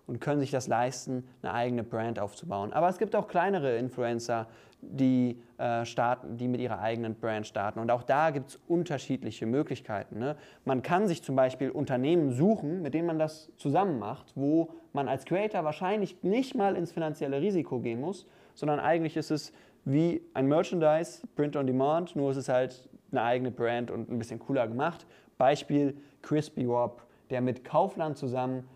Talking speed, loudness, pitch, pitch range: 175 wpm, -30 LUFS, 135 Hz, 120-160 Hz